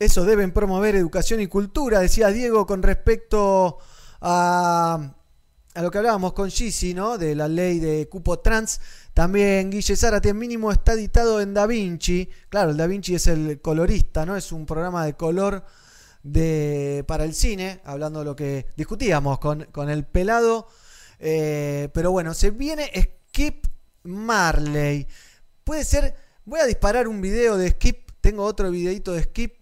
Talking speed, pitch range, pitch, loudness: 160 wpm, 155-210 Hz, 185 Hz, -23 LUFS